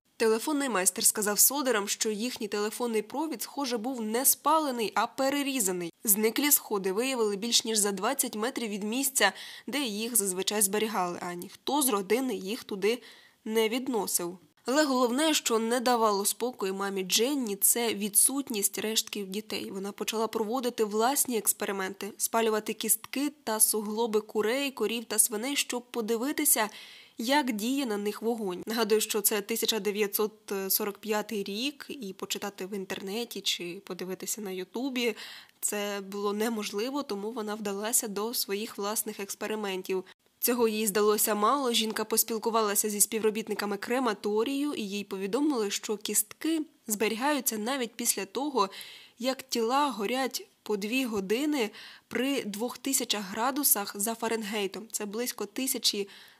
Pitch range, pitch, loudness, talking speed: 205-245 Hz, 220 Hz, -28 LUFS, 130 wpm